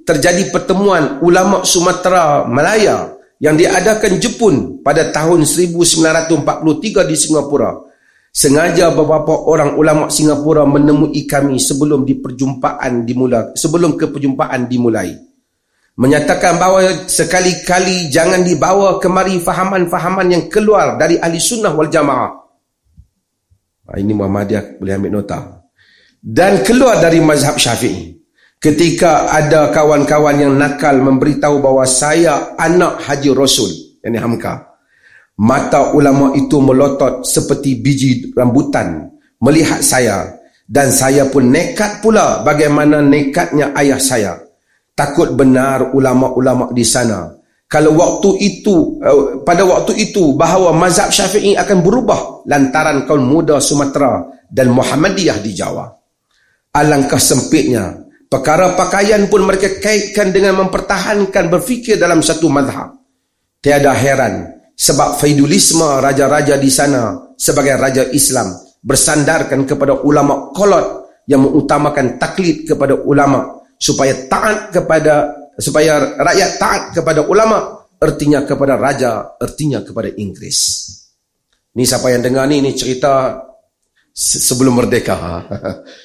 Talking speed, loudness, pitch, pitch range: 115 wpm, -12 LUFS, 150 Hz, 135-180 Hz